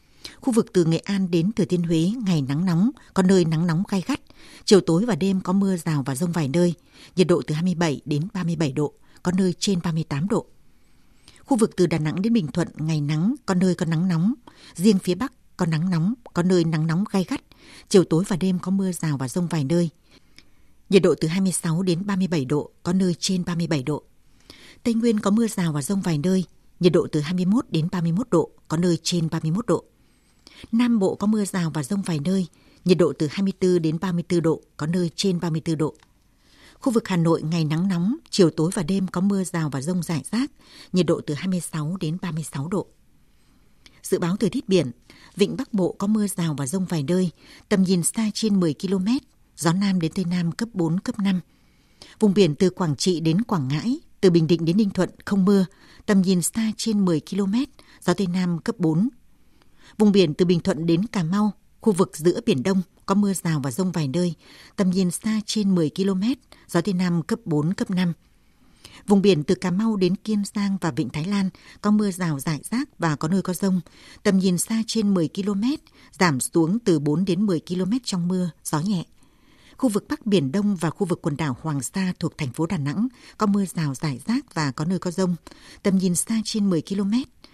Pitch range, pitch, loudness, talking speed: 165-200 Hz, 185 Hz, -23 LUFS, 220 wpm